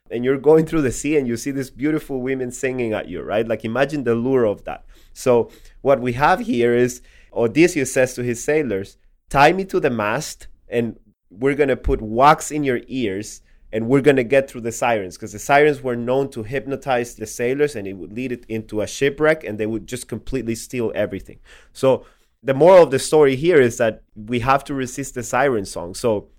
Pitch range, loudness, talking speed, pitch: 115-140 Hz, -19 LUFS, 220 wpm, 125 Hz